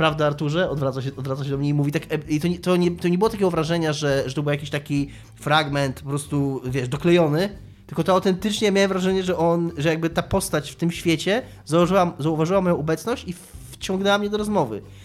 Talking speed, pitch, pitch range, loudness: 220 wpm, 160 Hz, 145-180 Hz, -22 LUFS